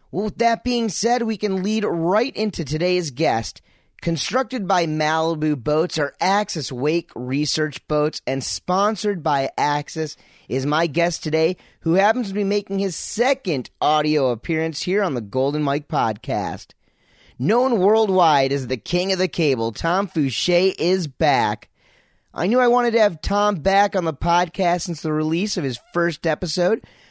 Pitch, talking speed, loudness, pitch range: 170 Hz, 165 wpm, -21 LUFS, 150-200 Hz